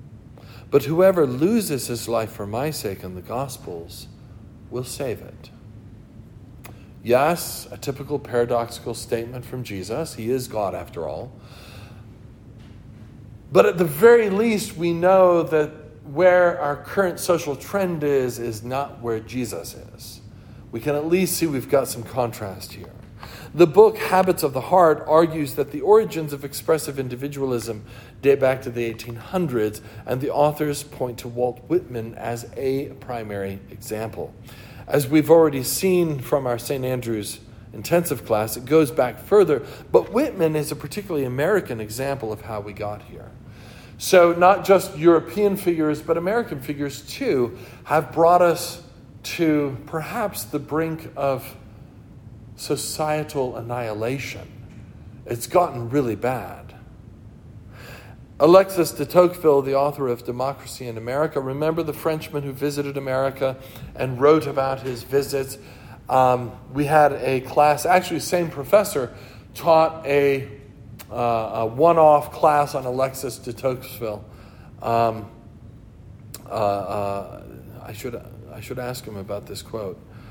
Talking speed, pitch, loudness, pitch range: 140 wpm, 130 Hz, -21 LUFS, 115-150 Hz